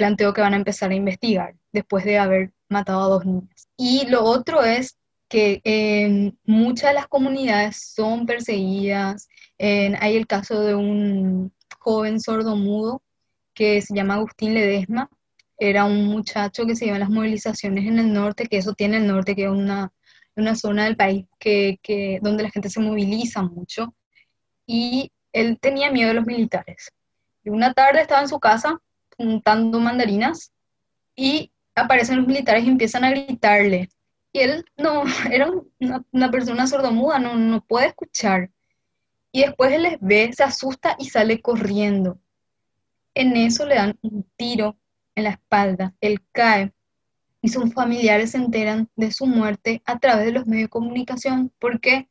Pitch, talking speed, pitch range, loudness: 220 Hz, 165 wpm, 205-250 Hz, -20 LUFS